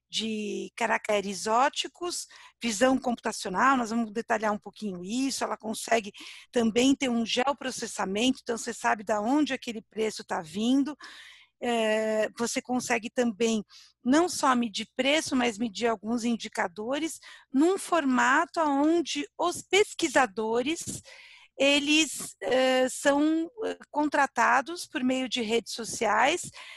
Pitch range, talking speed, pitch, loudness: 225-285 Hz, 110 wpm, 245 Hz, -27 LUFS